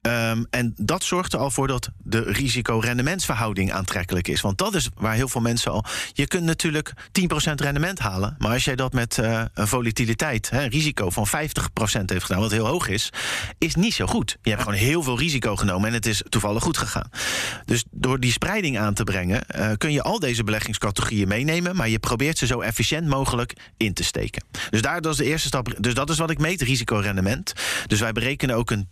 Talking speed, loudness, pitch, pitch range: 210 wpm, -23 LUFS, 120 Hz, 110-140 Hz